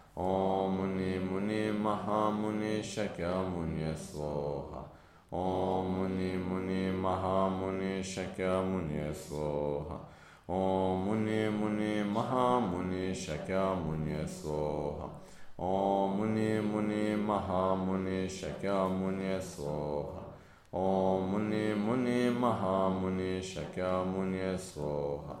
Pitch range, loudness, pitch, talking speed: 90-100 Hz, -33 LUFS, 95 Hz, 60 wpm